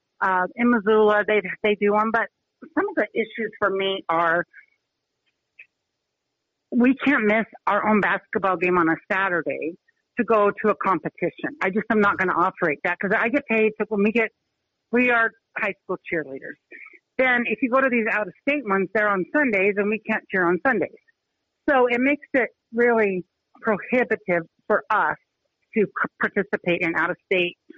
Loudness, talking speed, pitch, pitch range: -22 LUFS, 185 wpm, 210 Hz, 190-230 Hz